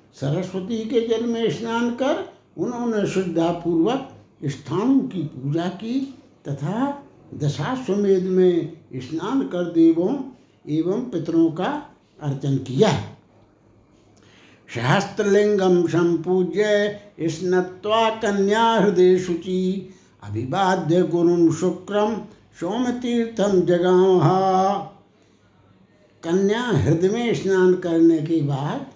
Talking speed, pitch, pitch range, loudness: 85 wpm, 185 Hz, 165-210 Hz, -21 LUFS